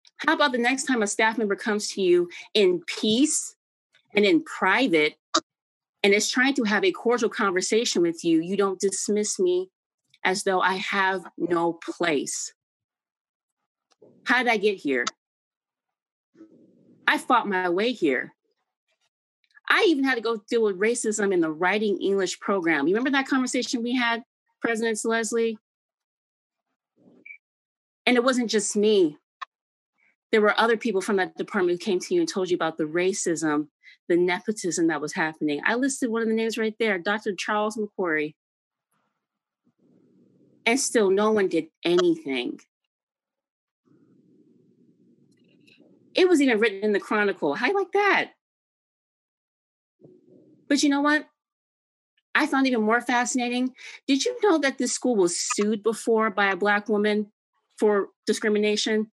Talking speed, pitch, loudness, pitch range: 150 wpm, 220 Hz, -24 LUFS, 195-260 Hz